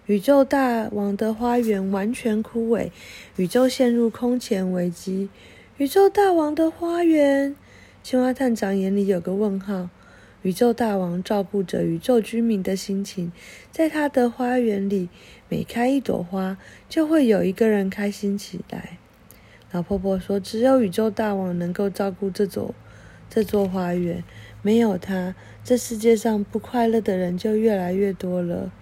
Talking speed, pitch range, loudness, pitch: 225 characters per minute, 190-240 Hz, -22 LUFS, 205 Hz